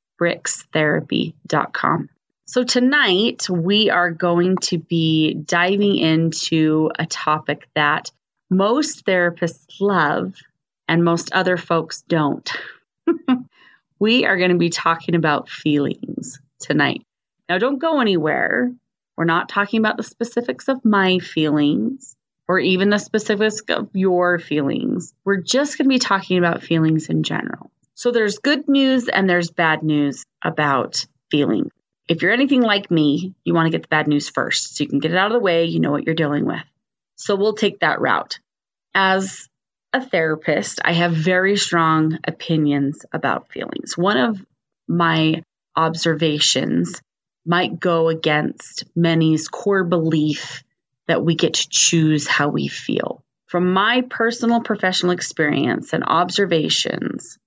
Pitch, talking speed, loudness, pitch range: 175 Hz, 145 wpm, -19 LUFS, 160-205 Hz